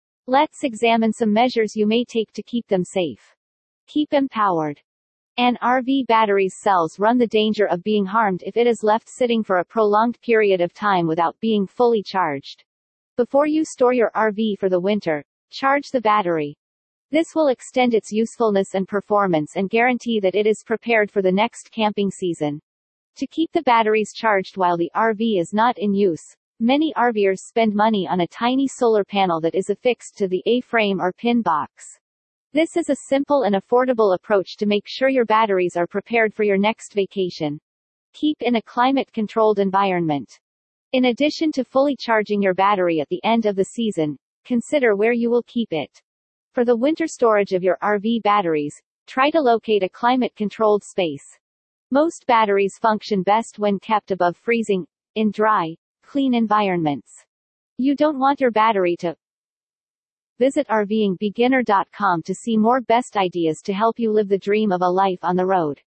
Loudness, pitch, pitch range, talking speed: -20 LUFS, 215 Hz, 190-240 Hz, 175 wpm